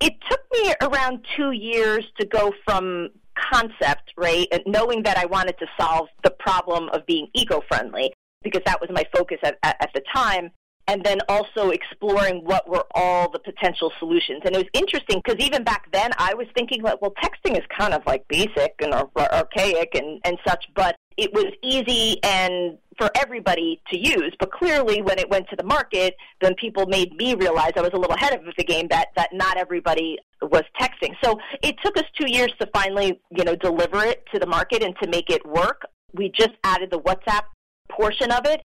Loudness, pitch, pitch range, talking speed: -22 LUFS, 200 Hz, 180-260 Hz, 205 wpm